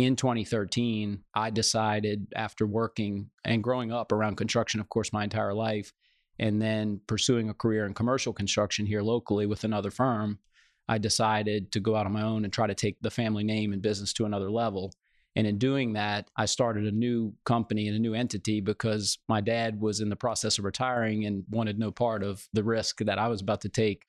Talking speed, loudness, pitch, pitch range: 210 wpm, -29 LUFS, 110 Hz, 105-115 Hz